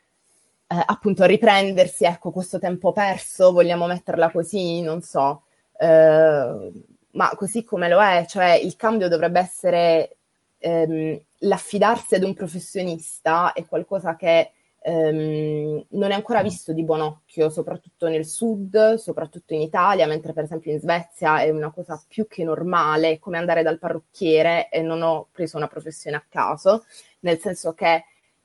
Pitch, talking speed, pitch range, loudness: 170 Hz, 150 wpm, 160-185 Hz, -21 LUFS